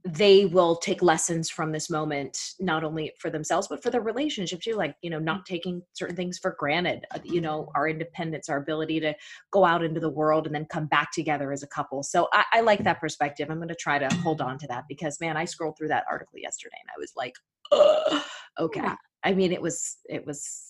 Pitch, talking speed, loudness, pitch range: 165 Hz, 235 wpm, -26 LUFS, 155-185 Hz